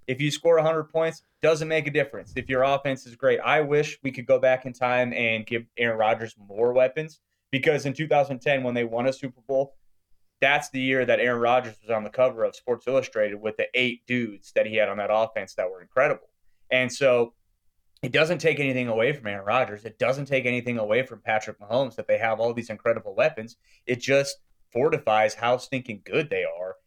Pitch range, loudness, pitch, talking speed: 110-140 Hz, -25 LUFS, 125 Hz, 215 wpm